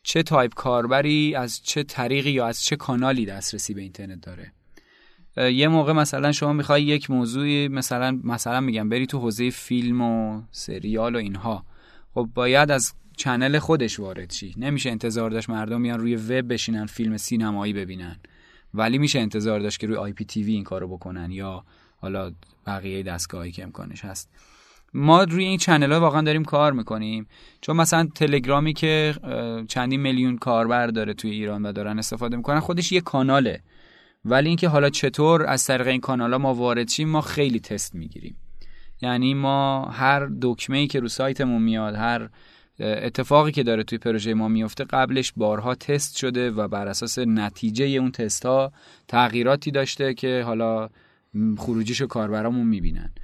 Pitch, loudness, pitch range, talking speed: 120 Hz, -23 LUFS, 110-140 Hz, 160 wpm